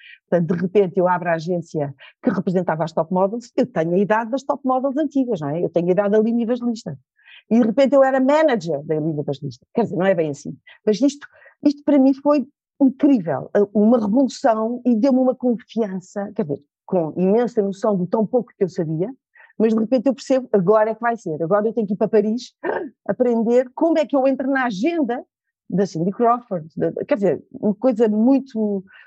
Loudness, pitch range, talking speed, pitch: -20 LUFS, 190-265 Hz, 210 wpm, 225 Hz